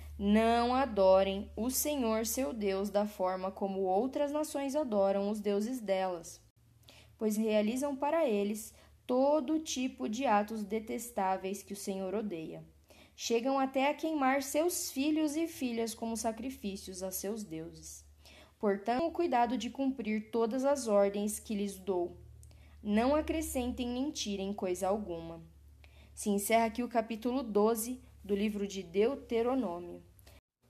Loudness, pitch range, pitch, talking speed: -33 LUFS, 190-255 Hz, 215 Hz, 135 wpm